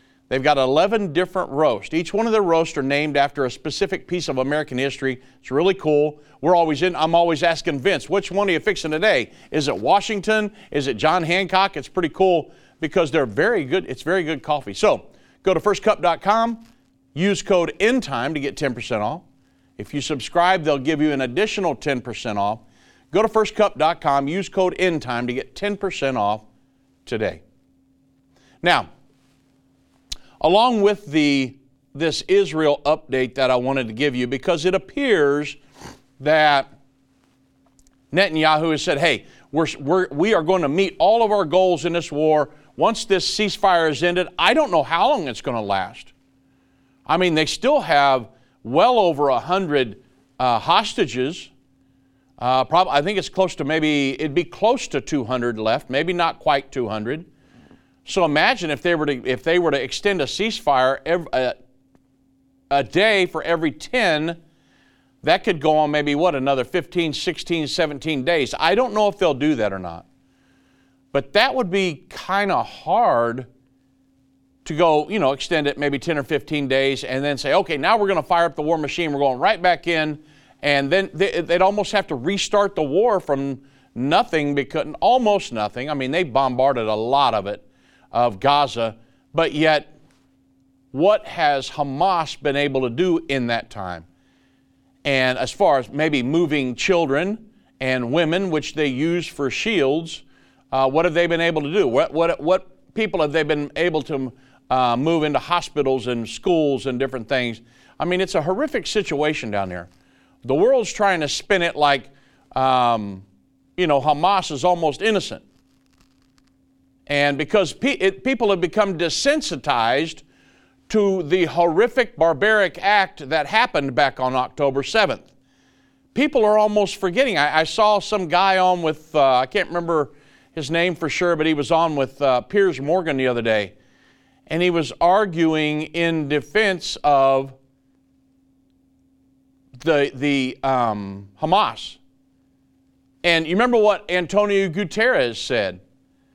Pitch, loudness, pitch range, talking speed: 150 Hz, -20 LUFS, 135-180 Hz, 165 wpm